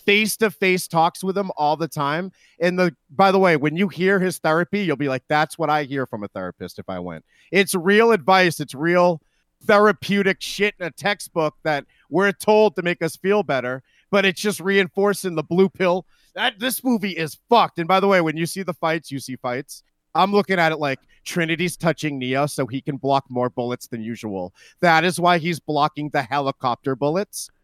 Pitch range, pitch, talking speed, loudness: 145-195 Hz, 170 Hz, 215 wpm, -20 LUFS